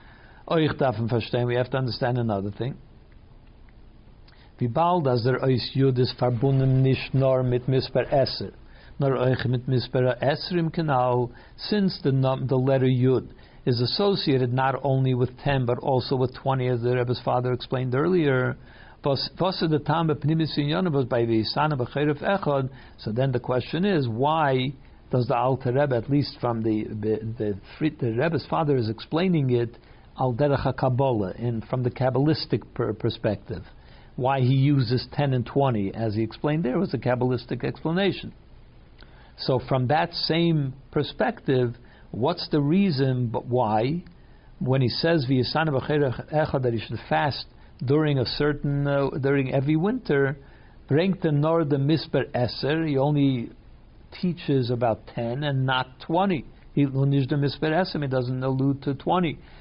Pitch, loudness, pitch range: 130 Hz, -24 LUFS, 125-150 Hz